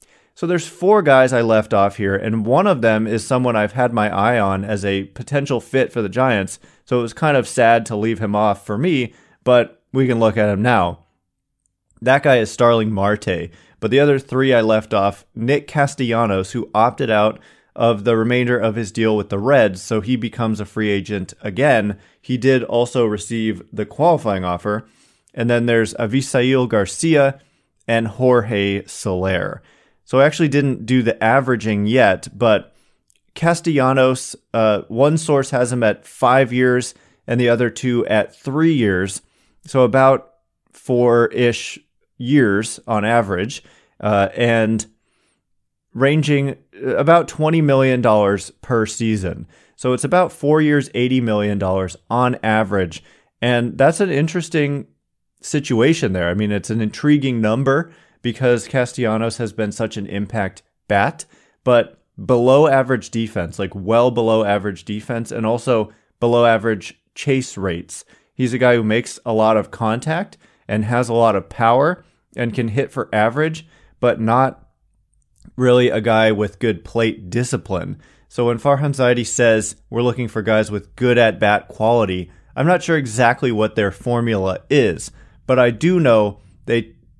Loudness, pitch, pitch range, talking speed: -17 LUFS, 115 Hz, 105-130 Hz, 160 wpm